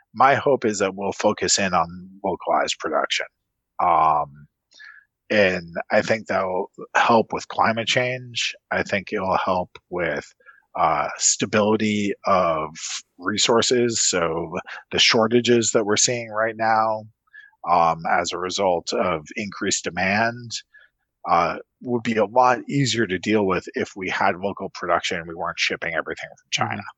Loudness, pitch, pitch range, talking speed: -21 LUFS, 110 Hz, 105-120 Hz, 145 wpm